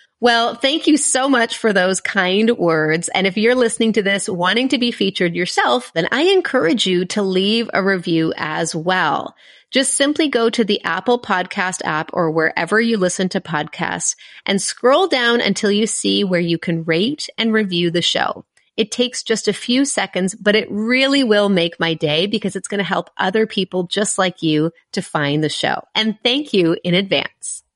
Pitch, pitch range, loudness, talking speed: 200 Hz, 180-235 Hz, -17 LUFS, 195 wpm